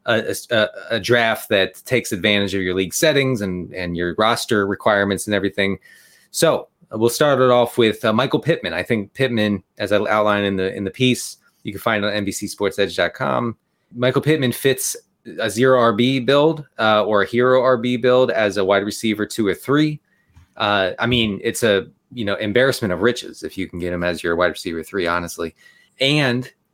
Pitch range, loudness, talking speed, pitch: 100-125 Hz, -19 LUFS, 195 wpm, 110 Hz